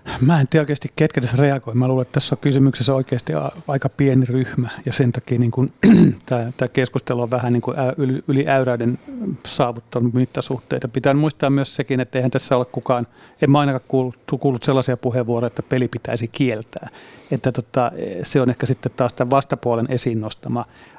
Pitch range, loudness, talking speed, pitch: 125-140 Hz, -20 LUFS, 170 wpm, 130 Hz